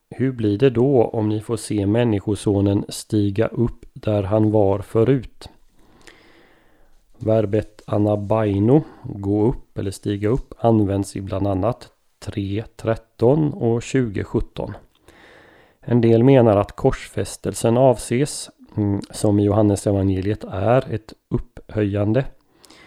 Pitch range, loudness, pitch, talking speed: 100-120 Hz, -20 LUFS, 110 Hz, 110 wpm